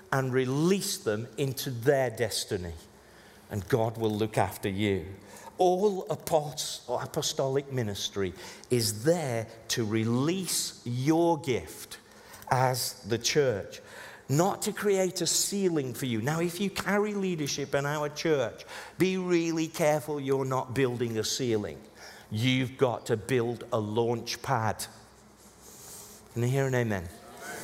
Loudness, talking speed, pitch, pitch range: -29 LUFS, 130 wpm, 135 Hz, 115-165 Hz